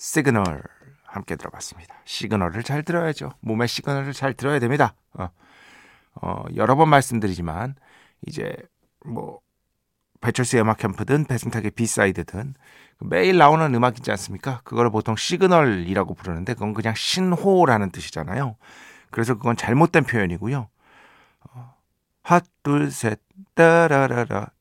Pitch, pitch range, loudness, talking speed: 120 Hz, 105-145 Hz, -21 LUFS, 305 characters per minute